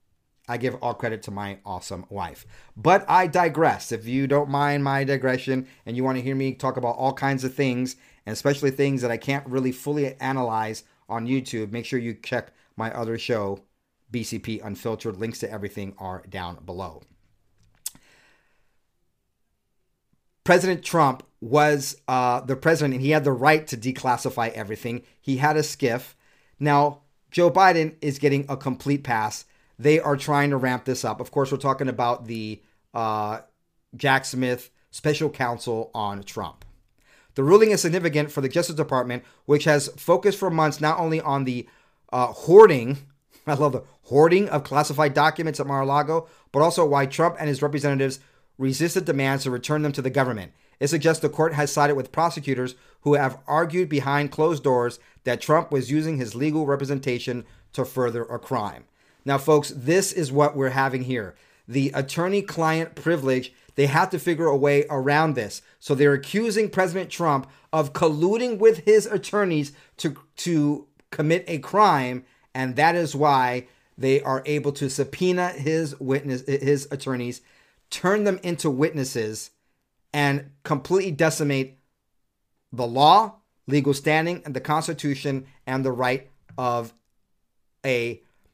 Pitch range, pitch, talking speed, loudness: 125-155 Hz, 140 Hz, 160 wpm, -23 LUFS